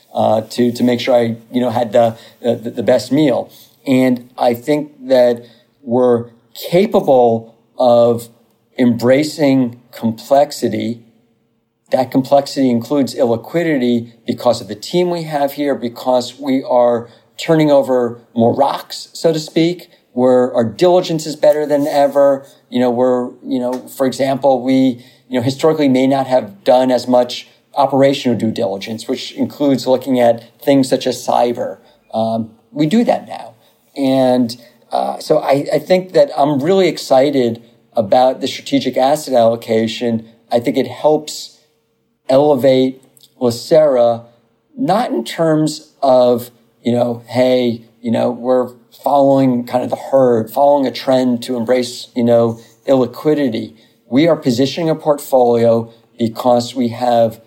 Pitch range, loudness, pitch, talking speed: 115-140 Hz, -15 LUFS, 125 Hz, 140 wpm